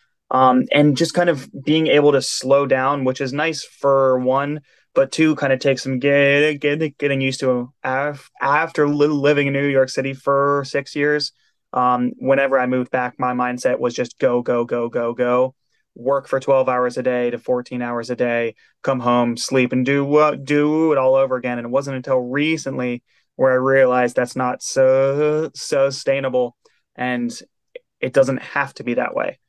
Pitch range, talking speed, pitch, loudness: 125-140 Hz, 190 wpm, 135 Hz, -19 LUFS